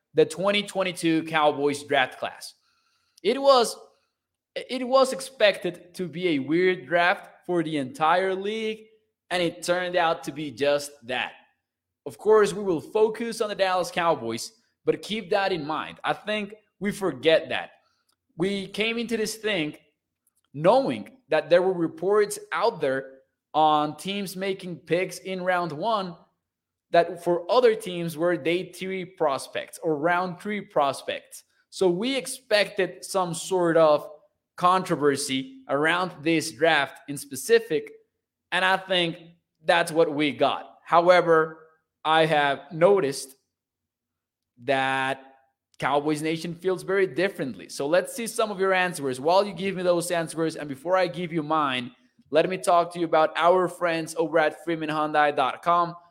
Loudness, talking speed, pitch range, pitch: -25 LUFS, 145 wpm, 155-195 Hz, 175 Hz